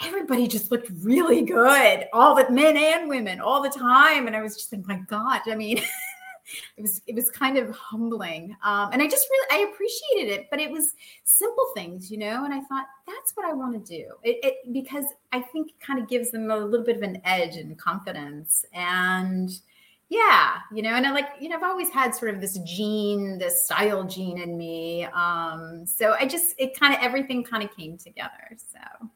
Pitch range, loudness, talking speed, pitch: 200-280 Hz, -23 LUFS, 220 wpm, 240 Hz